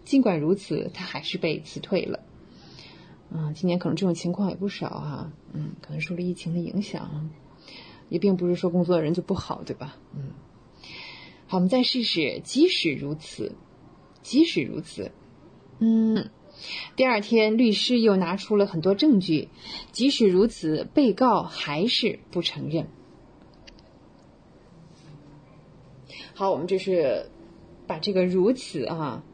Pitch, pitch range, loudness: 185 Hz, 165-215 Hz, -25 LUFS